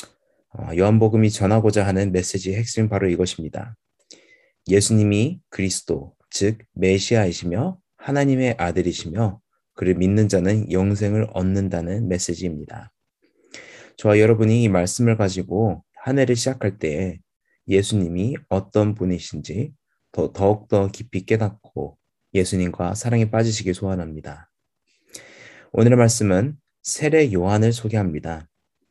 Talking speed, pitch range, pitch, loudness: 290 characters per minute, 90-110 Hz, 100 Hz, -21 LUFS